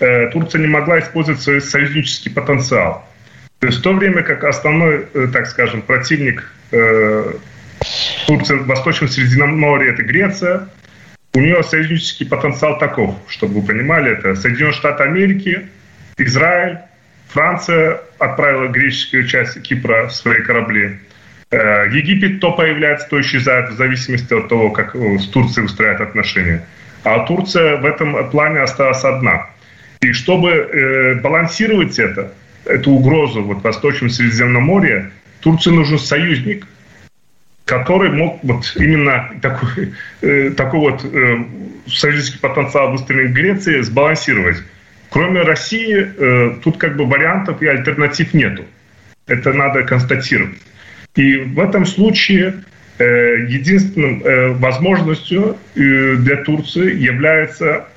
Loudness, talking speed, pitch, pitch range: -13 LUFS, 125 wpm, 140 Hz, 125-160 Hz